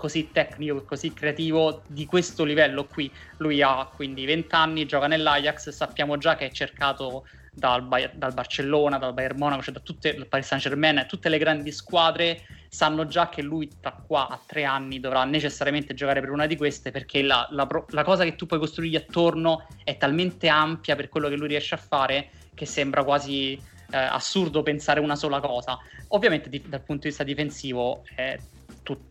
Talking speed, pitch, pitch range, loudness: 185 wpm, 145 Hz, 140-155 Hz, -25 LUFS